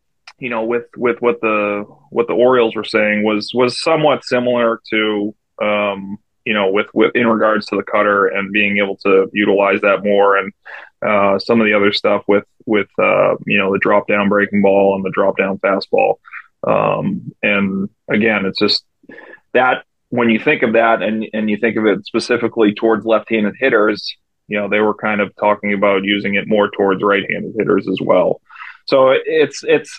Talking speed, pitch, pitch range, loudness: 195 wpm, 105 Hz, 100-115 Hz, -15 LUFS